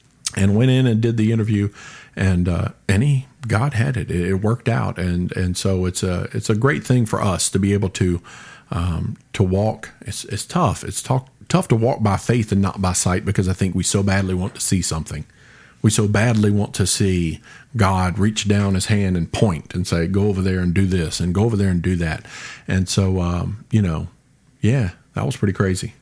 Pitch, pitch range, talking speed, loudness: 100 Hz, 90-115 Hz, 220 wpm, -20 LUFS